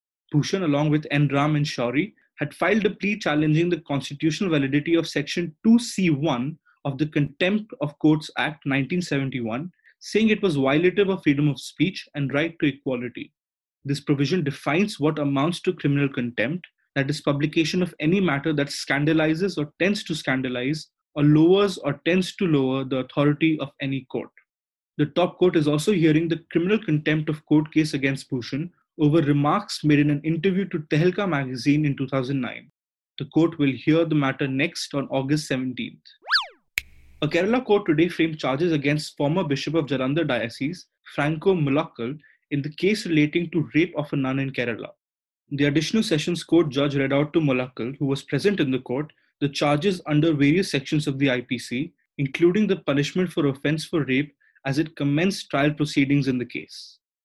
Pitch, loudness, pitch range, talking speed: 150 Hz, -23 LUFS, 140-165 Hz, 175 wpm